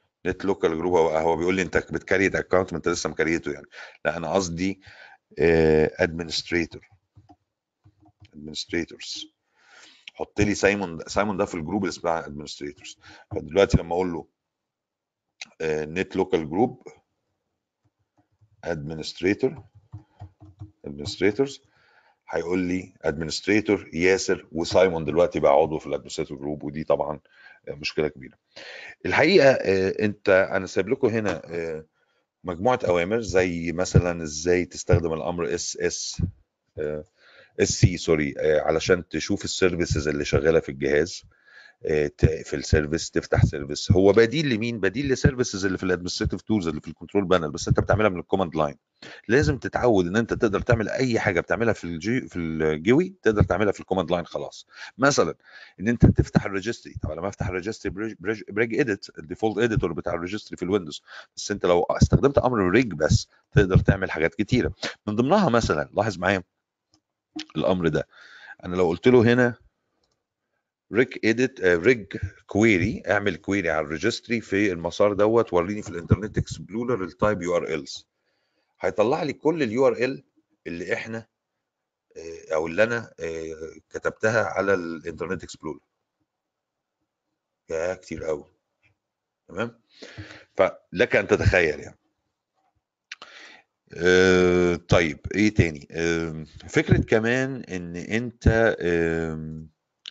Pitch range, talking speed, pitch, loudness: 85-110 Hz, 130 wpm, 95 Hz, -24 LUFS